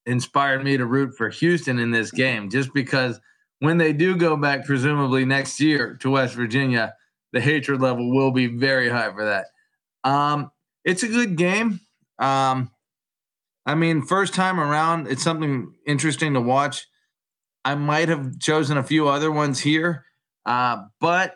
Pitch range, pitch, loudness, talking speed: 130-160 Hz, 140 Hz, -21 LUFS, 165 wpm